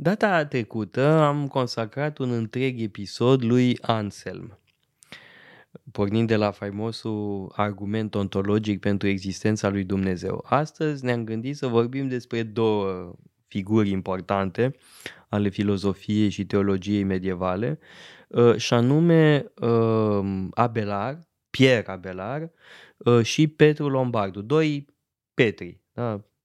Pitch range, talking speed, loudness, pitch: 100-130 Hz, 100 wpm, -24 LUFS, 115 Hz